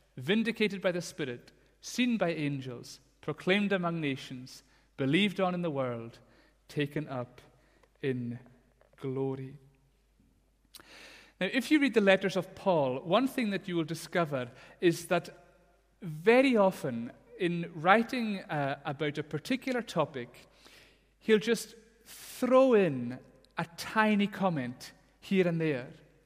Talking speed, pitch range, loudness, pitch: 125 wpm, 140-200 Hz, -30 LUFS, 170 Hz